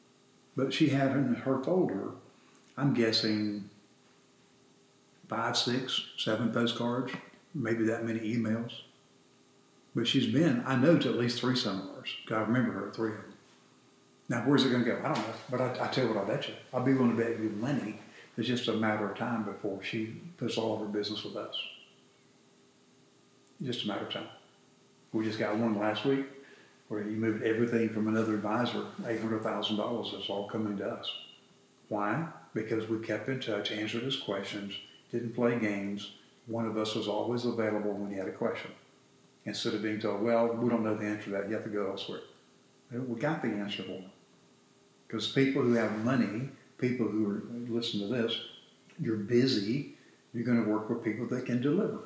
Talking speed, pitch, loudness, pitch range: 190 wpm, 110 Hz, -32 LUFS, 105-120 Hz